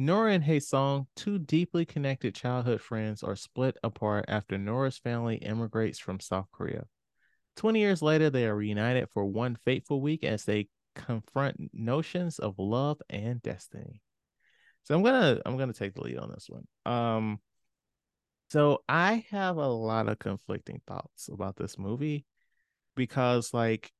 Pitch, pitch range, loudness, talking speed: 120 Hz, 110-145 Hz, -30 LUFS, 160 wpm